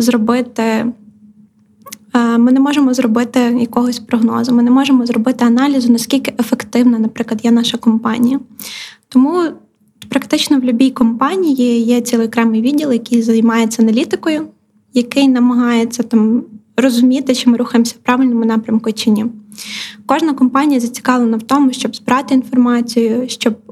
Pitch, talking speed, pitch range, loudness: 240 Hz, 130 wpm, 230-255 Hz, -13 LUFS